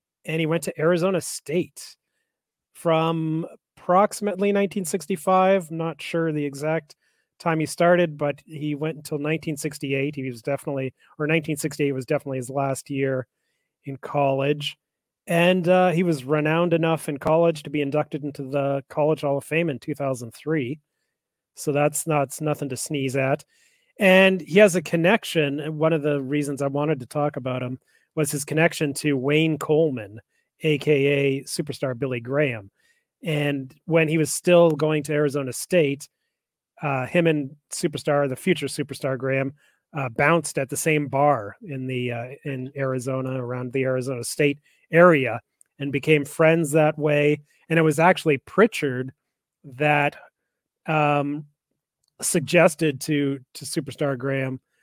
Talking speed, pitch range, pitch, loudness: 150 wpm, 140-165 Hz, 150 Hz, -23 LUFS